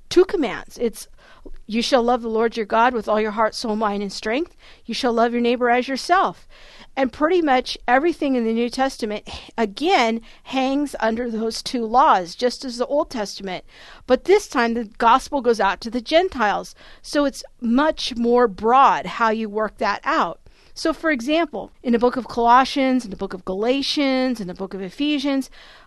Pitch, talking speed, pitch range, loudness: 245 Hz, 190 wpm, 225-270 Hz, -20 LUFS